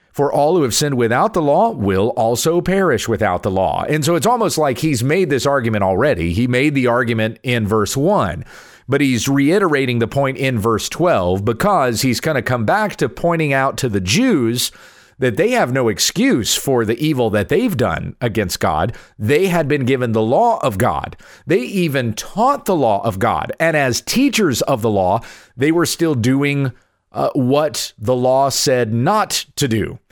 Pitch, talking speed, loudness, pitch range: 125 Hz, 195 wpm, -16 LUFS, 115-145 Hz